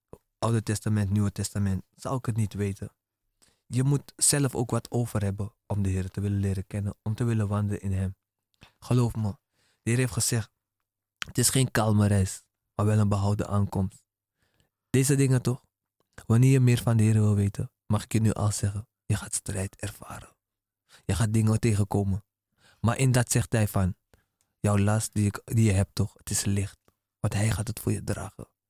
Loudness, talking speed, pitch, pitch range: -27 LUFS, 195 wpm, 105 Hz, 100-115 Hz